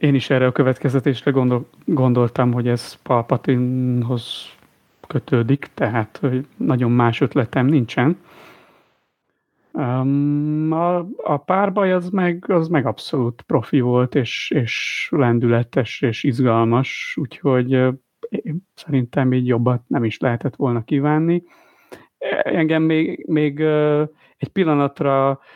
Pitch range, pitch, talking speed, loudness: 125-155 Hz, 135 Hz, 110 wpm, -19 LUFS